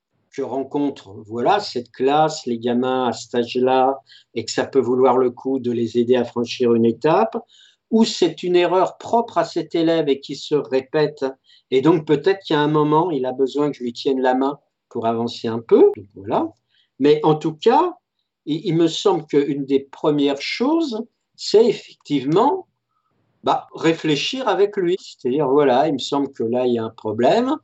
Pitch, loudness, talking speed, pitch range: 145 Hz, -19 LUFS, 195 wpm, 130-195 Hz